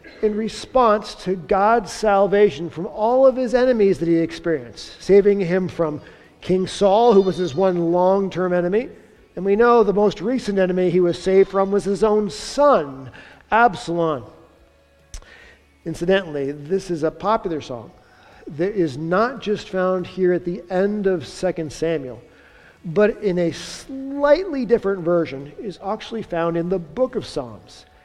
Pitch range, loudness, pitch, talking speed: 170-210 Hz, -20 LUFS, 190 Hz, 155 wpm